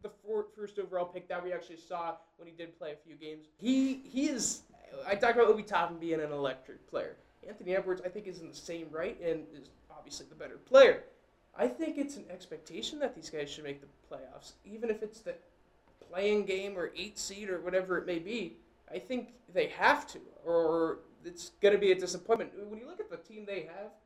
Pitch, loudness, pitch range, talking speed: 185 Hz, -32 LUFS, 170-215 Hz, 220 wpm